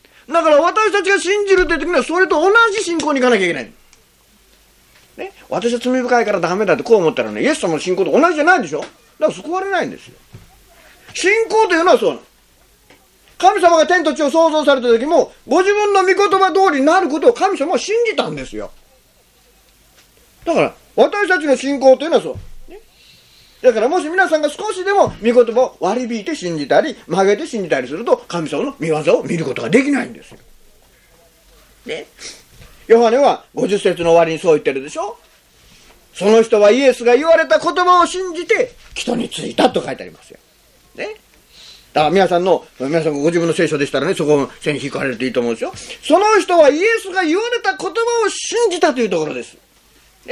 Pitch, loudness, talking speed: 320 Hz, -15 LUFS, 390 characters per minute